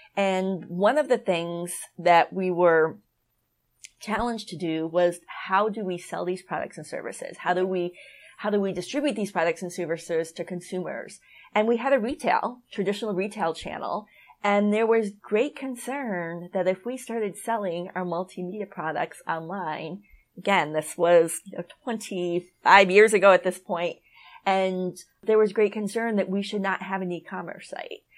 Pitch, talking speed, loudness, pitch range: 190 Hz, 170 wpm, -25 LUFS, 175-215 Hz